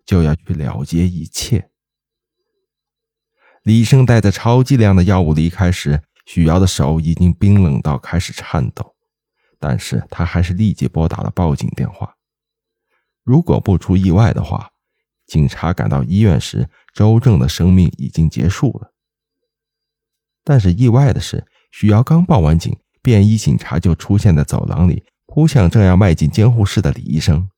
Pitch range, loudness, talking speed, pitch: 85-115 Hz, -14 LUFS, 235 characters per minute, 95 Hz